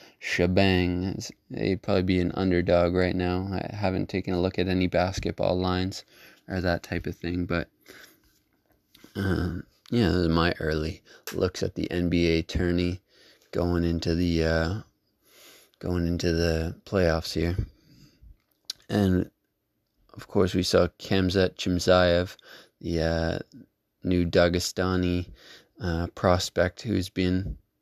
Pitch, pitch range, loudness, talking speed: 90 Hz, 85-95 Hz, -26 LUFS, 125 wpm